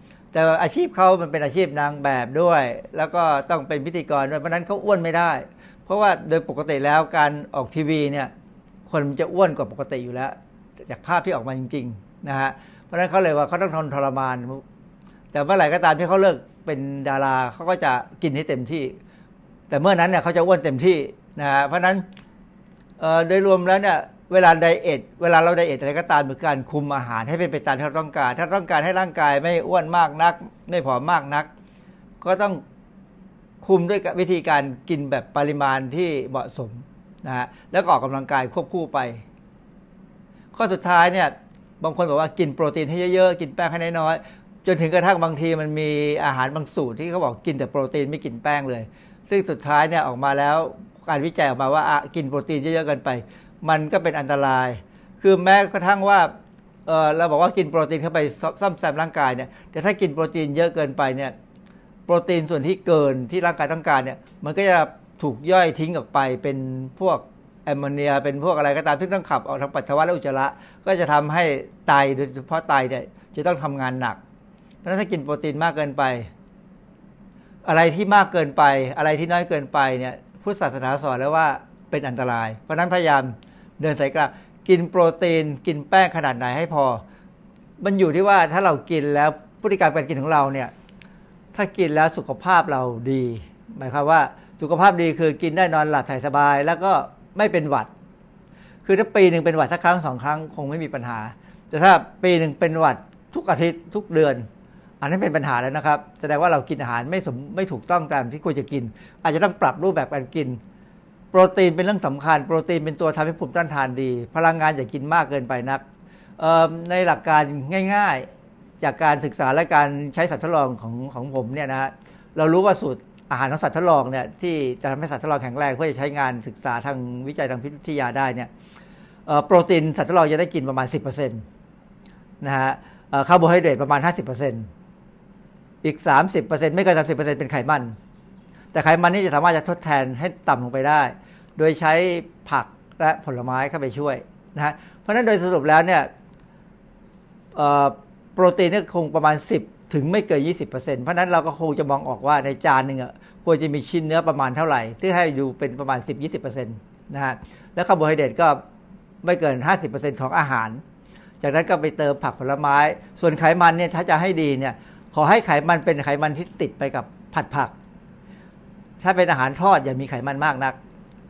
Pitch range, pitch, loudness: 140-185 Hz, 160 Hz, -21 LUFS